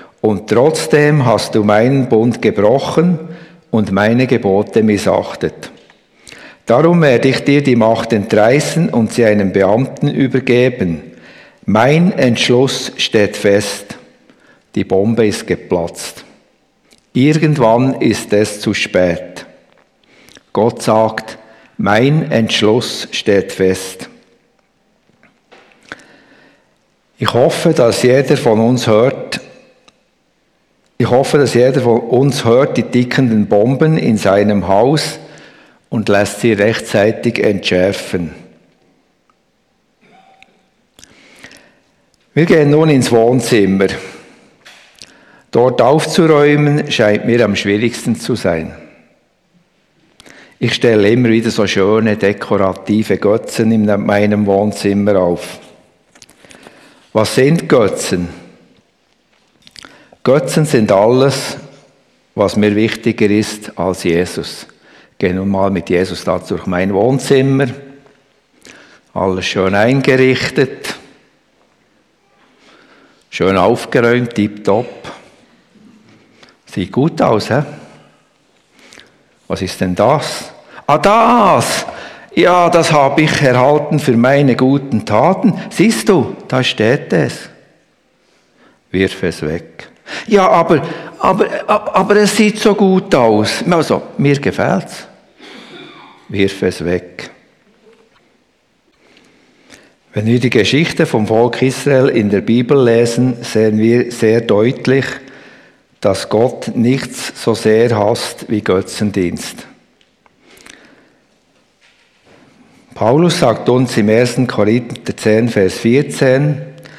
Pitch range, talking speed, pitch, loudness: 105-140 Hz, 100 wpm, 120 Hz, -13 LUFS